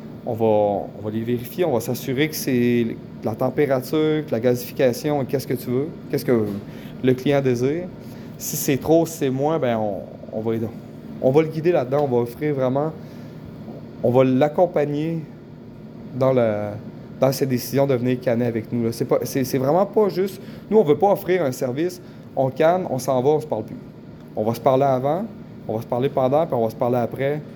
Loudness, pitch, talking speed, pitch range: -21 LUFS, 130 Hz, 210 wpm, 120-150 Hz